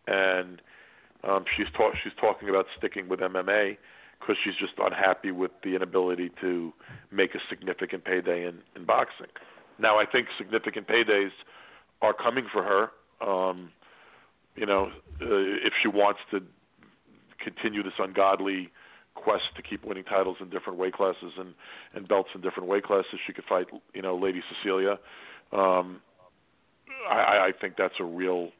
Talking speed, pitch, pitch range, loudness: 155 wpm, 95 Hz, 90-95 Hz, -28 LUFS